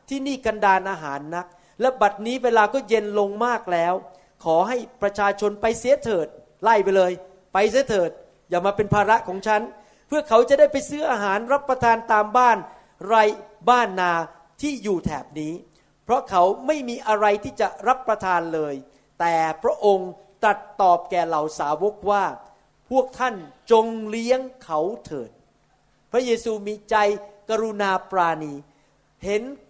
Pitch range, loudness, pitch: 180-235 Hz, -22 LUFS, 210 Hz